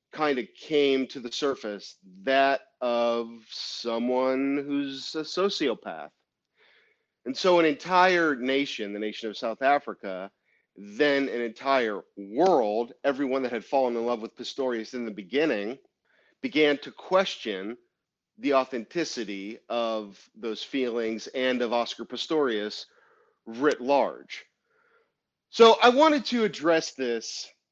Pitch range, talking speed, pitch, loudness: 115-150 Hz, 125 wpm, 130 Hz, -26 LUFS